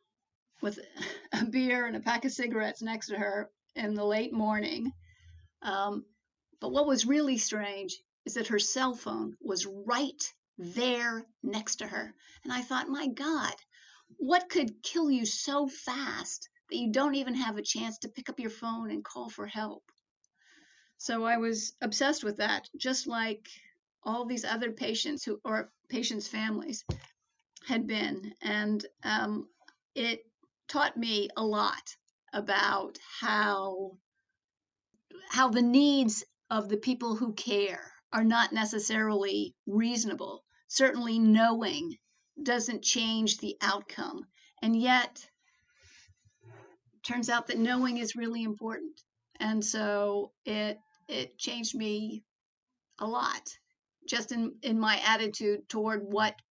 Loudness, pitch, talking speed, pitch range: -31 LUFS, 230 Hz, 135 wpm, 215-260 Hz